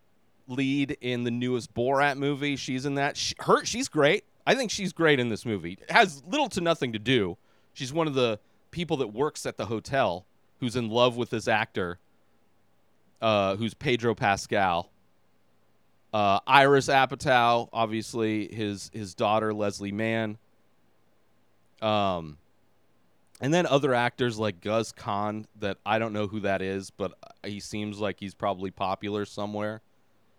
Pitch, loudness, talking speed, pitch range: 115 Hz, -27 LUFS, 155 wpm, 105-130 Hz